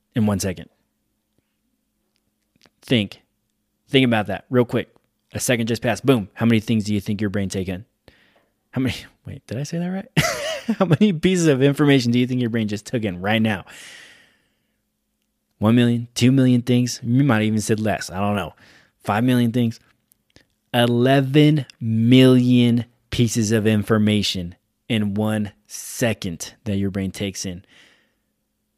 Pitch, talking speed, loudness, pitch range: 115 Hz, 160 wpm, -20 LUFS, 105-125 Hz